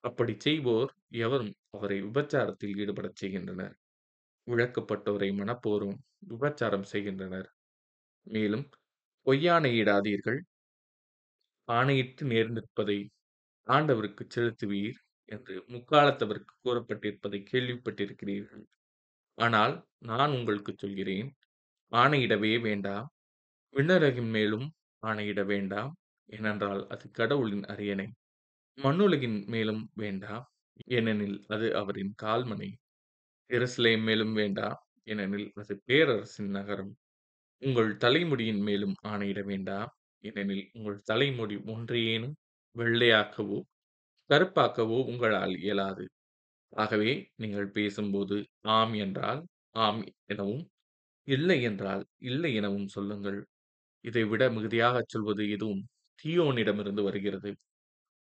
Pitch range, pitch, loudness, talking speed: 100-120 Hz, 105 Hz, -30 LUFS, 85 wpm